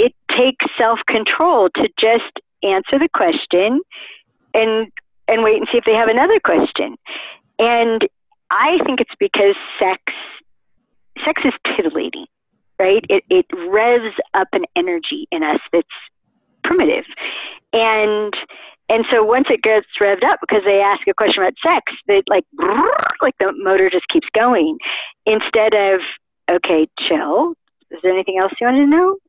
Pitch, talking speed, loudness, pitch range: 230 Hz, 150 wpm, -16 LUFS, 205-325 Hz